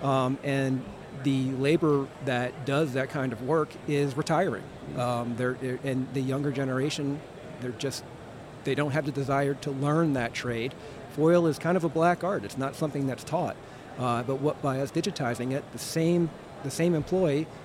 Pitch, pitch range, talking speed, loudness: 140 Hz, 130-155 Hz, 185 wpm, -28 LUFS